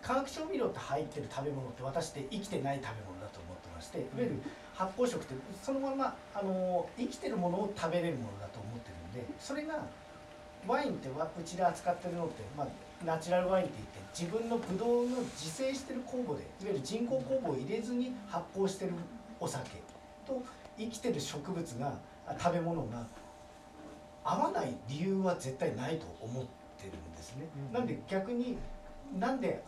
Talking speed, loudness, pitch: 370 characters per minute, -37 LUFS, 175 Hz